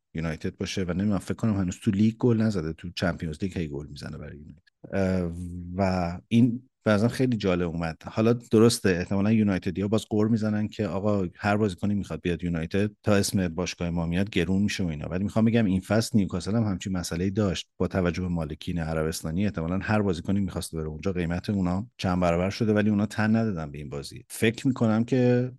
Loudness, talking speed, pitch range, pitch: -26 LUFS, 200 wpm, 90-110 Hz, 95 Hz